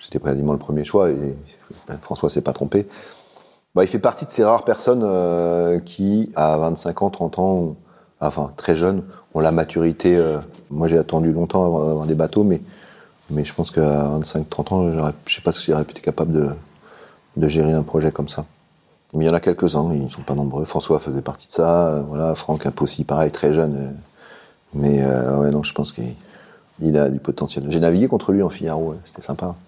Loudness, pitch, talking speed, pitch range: -20 LUFS, 80 Hz, 225 wpm, 75-85 Hz